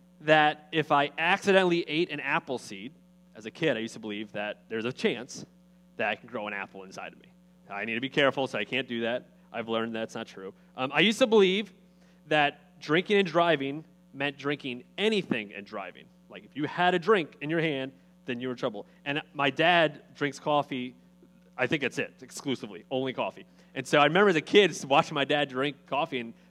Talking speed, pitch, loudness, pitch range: 215 wpm, 150 Hz, -28 LUFS, 130-180 Hz